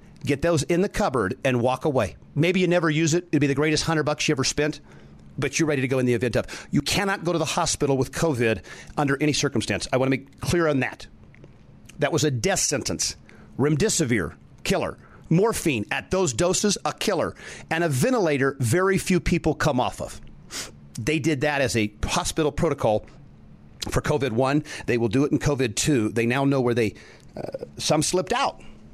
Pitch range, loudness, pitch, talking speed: 125-165 Hz, -23 LUFS, 145 Hz, 195 wpm